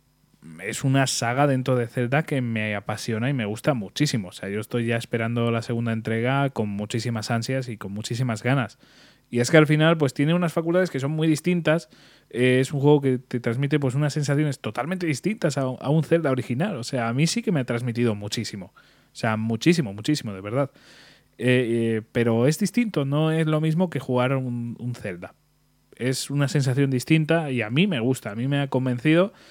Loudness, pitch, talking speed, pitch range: -24 LUFS, 130 Hz, 210 wpm, 115-150 Hz